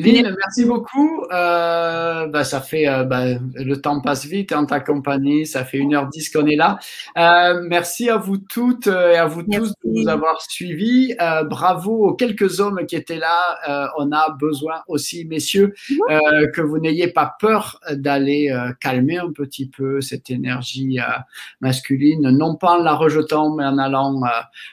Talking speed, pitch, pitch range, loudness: 185 wpm, 155 Hz, 140-175 Hz, -18 LUFS